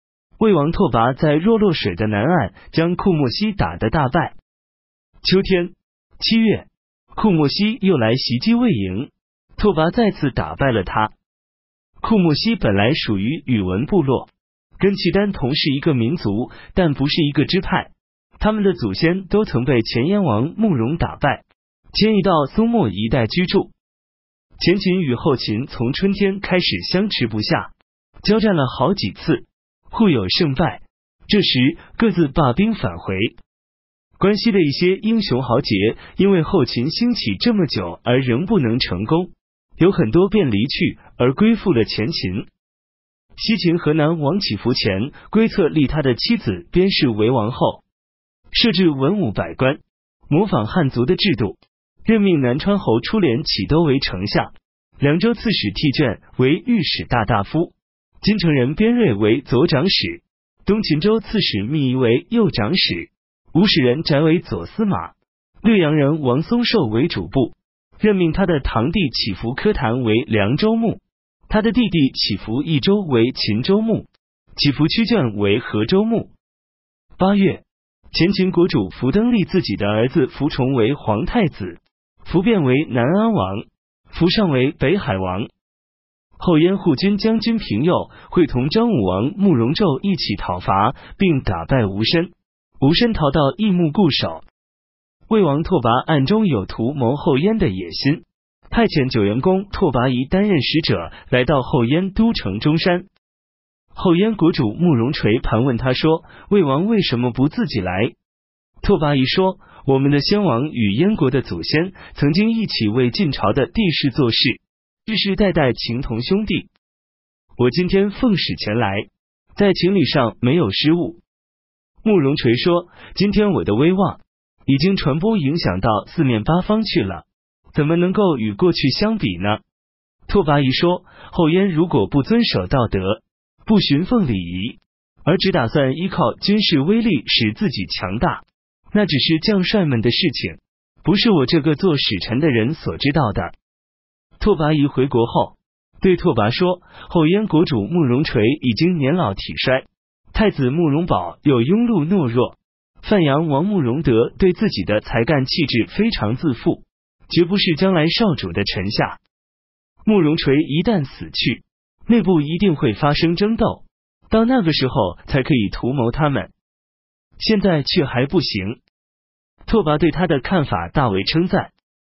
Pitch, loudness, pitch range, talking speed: 155 Hz, -18 LUFS, 115-190 Hz, 225 characters per minute